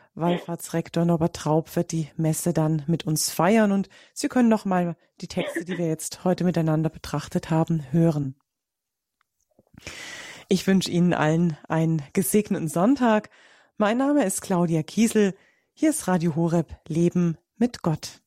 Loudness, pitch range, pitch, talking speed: -24 LUFS, 160-195 Hz, 170 Hz, 140 wpm